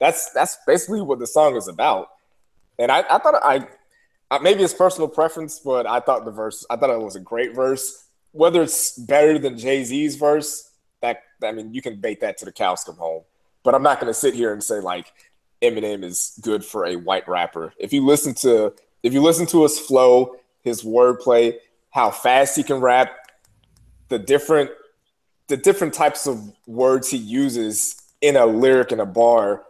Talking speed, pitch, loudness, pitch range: 195 wpm, 135 Hz, -19 LUFS, 120-160 Hz